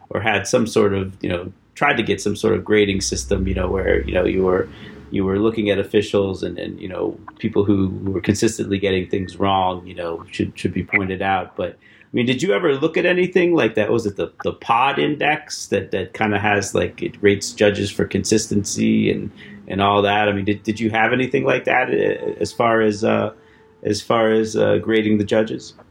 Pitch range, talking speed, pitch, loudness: 95-110 Hz, 225 wpm, 105 Hz, -19 LUFS